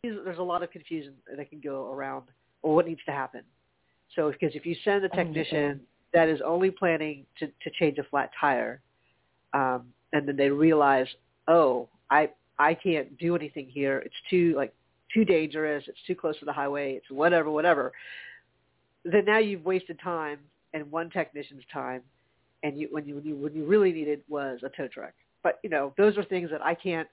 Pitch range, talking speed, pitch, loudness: 140-170 Hz, 195 wpm, 150 Hz, -28 LUFS